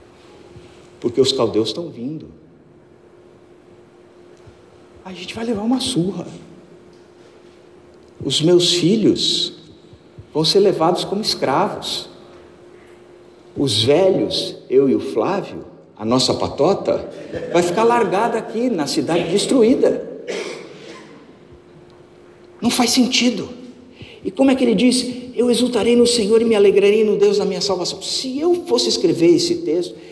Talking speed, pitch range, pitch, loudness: 125 wpm, 185-255 Hz, 225 Hz, -17 LUFS